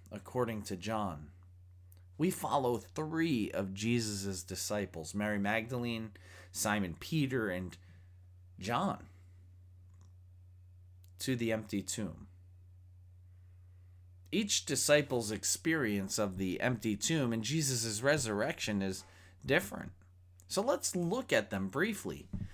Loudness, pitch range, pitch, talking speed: -35 LUFS, 90-115 Hz, 95 Hz, 100 wpm